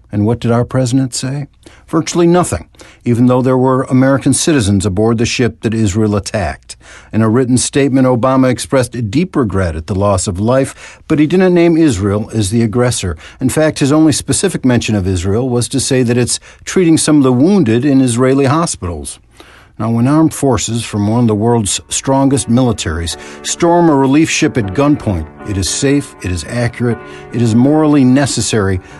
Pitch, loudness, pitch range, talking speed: 120 Hz, -12 LUFS, 105-140 Hz, 185 wpm